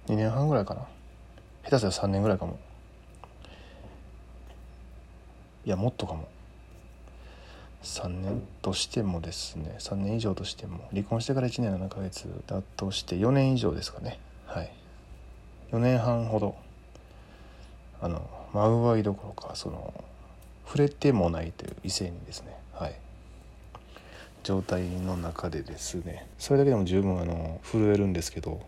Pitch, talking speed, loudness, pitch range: 95 Hz, 250 characters per minute, -30 LUFS, 80-105 Hz